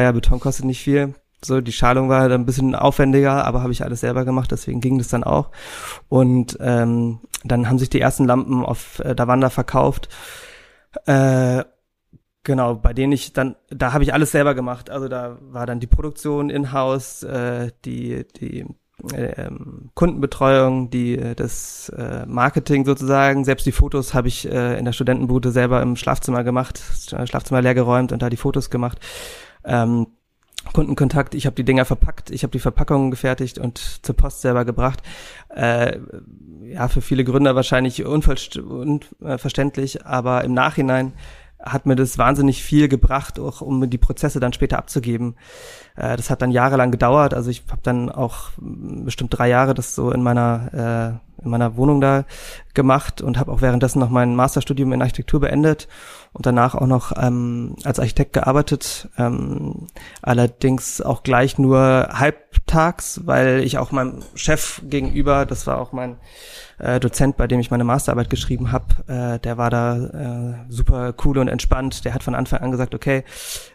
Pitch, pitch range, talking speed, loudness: 130 Hz, 125-140 Hz, 170 wpm, -19 LUFS